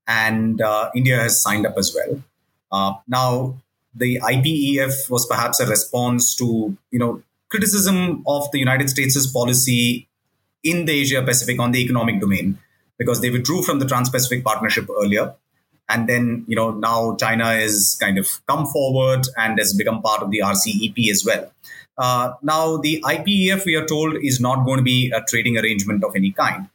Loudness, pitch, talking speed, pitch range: -18 LUFS, 125 Hz, 175 wpm, 115-140 Hz